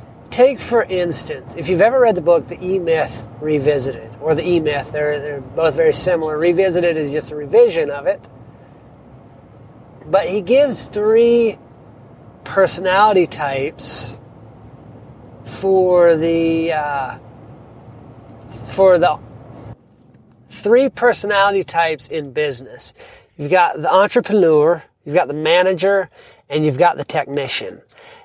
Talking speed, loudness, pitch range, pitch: 125 wpm, -16 LUFS, 135-190 Hz, 160 Hz